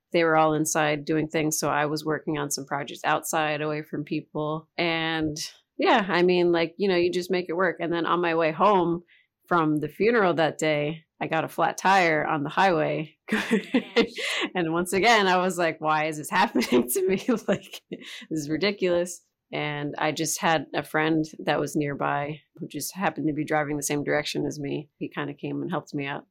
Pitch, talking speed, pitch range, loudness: 160 Hz, 210 wpm, 150-175 Hz, -25 LUFS